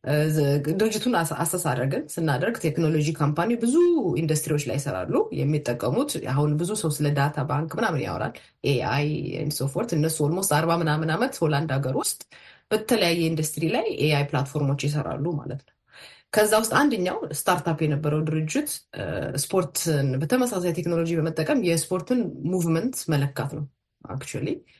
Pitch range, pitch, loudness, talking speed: 145-170 Hz, 155 Hz, -25 LUFS, 125 wpm